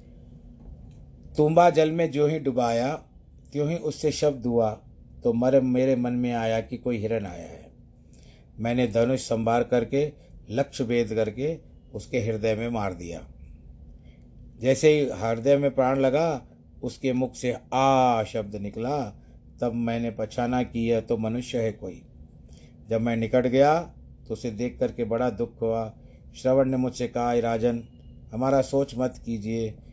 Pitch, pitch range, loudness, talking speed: 120 Hz, 110-130 Hz, -25 LUFS, 145 wpm